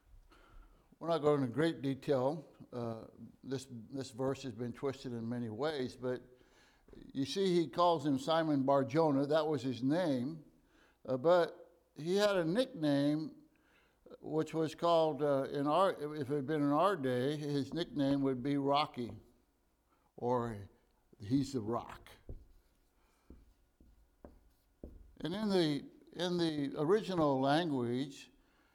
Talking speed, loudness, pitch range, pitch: 135 wpm, -35 LUFS, 125-160 Hz, 140 Hz